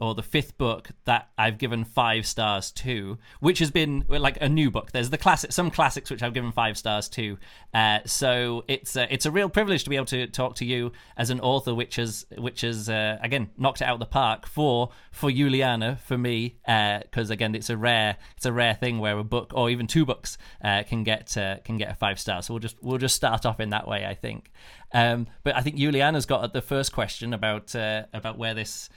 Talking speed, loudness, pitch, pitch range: 240 wpm, -26 LUFS, 120 Hz, 110-135 Hz